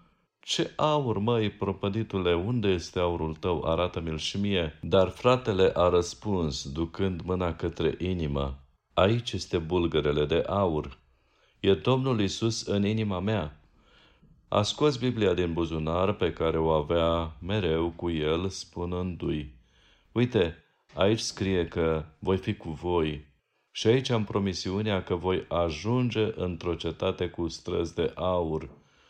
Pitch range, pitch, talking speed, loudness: 80-100 Hz, 90 Hz, 130 wpm, -28 LUFS